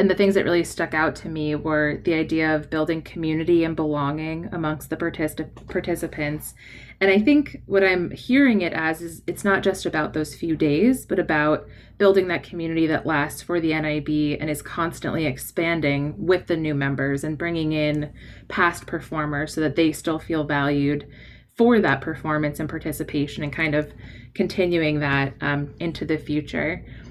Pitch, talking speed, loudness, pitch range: 155 Hz, 175 wpm, -23 LUFS, 150-170 Hz